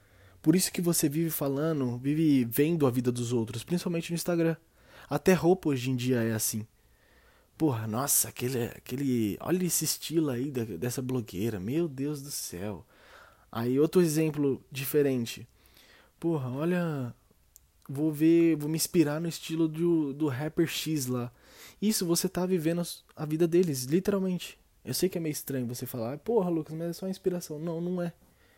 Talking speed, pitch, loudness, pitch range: 170 wpm, 150 Hz, -29 LUFS, 125-170 Hz